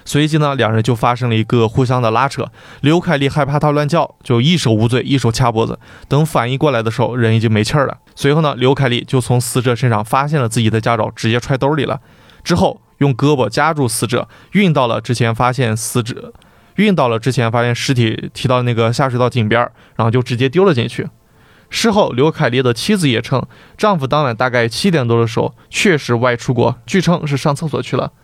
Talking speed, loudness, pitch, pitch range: 330 characters per minute, -15 LUFS, 125 Hz, 115-145 Hz